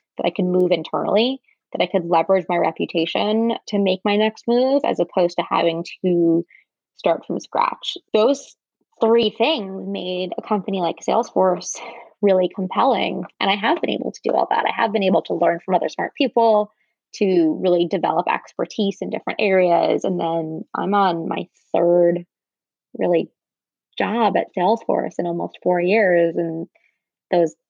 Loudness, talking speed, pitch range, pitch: -20 LUFS, 165 wpm, 175-215 Hz, 190 Hz